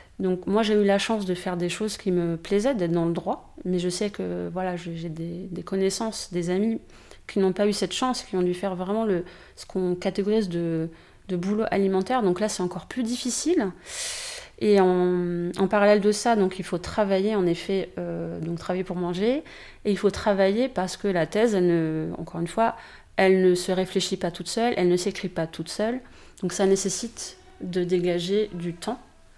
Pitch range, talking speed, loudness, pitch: 180-210 Hz, 210 wpm, -25 LUFS, 190 Hz